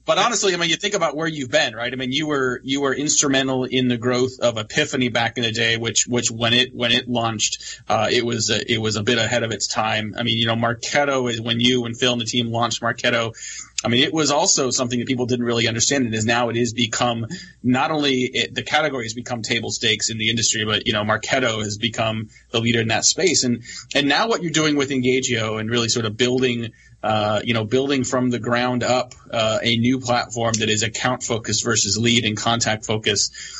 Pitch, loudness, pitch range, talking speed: 120 Hz, -20 LUFS, 115-130 Hz, 240 wpm